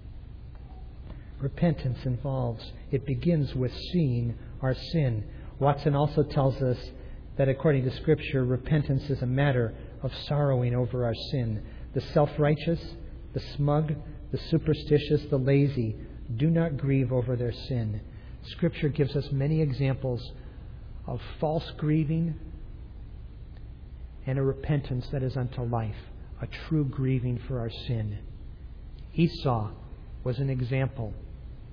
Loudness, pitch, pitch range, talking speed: -29 LUFS, 130 Hz, 120-145 Hz, 120 wpm